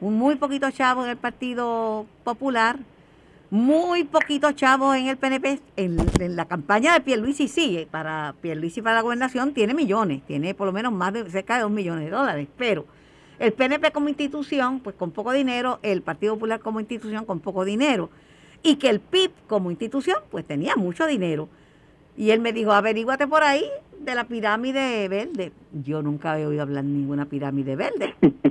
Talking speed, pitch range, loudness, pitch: 180 wpm, 190-270 Hz, -23 LUFS, 225 Hz